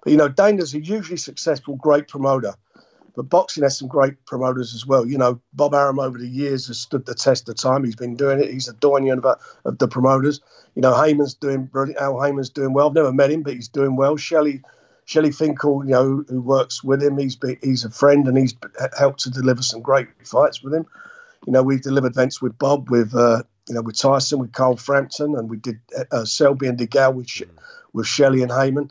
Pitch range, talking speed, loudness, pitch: 130-145 Hz, 230 wpm, -19 LUFS, 135 Hz